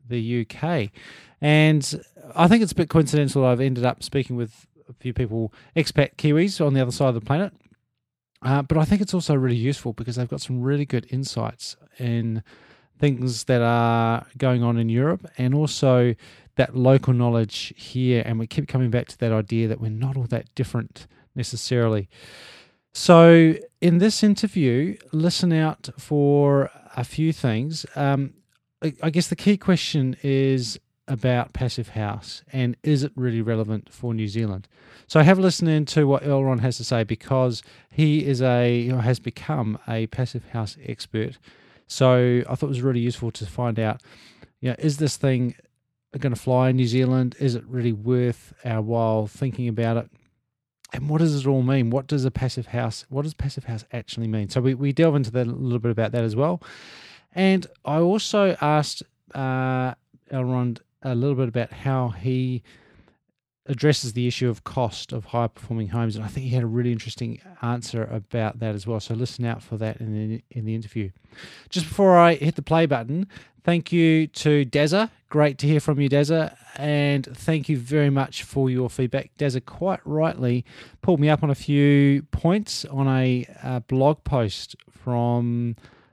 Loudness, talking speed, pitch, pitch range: -22 LUFS, 185 wpm, 130 Hz, 120-150 Hz